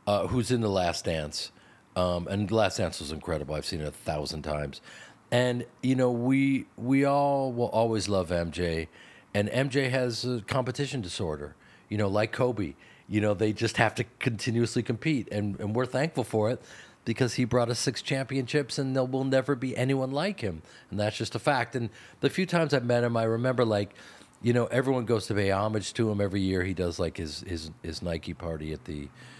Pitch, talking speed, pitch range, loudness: 115 Hz, 210 wpm, 95-130 Hz, -29 LUFS